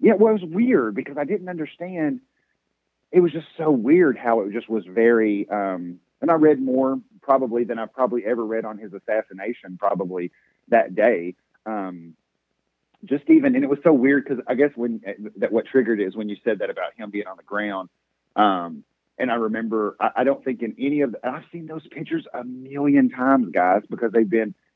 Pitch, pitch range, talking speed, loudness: 125 Hz, 105-145 Hz, 210 wpm, -22 LUFS